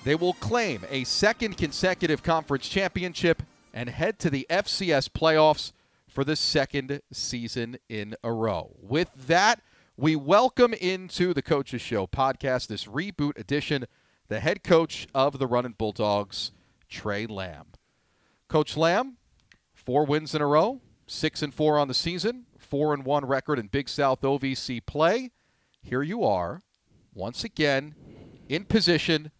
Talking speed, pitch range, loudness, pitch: 140 wpm, 120-165 Hz, -26 LUFS, 145 Hz